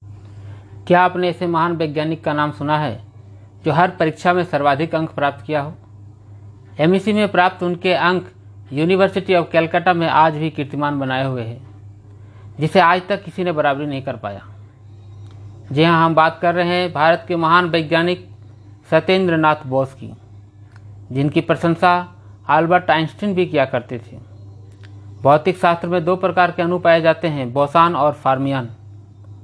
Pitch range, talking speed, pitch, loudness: 105-170 Hz, 160 wpm, 150 Hz, -17 LUFS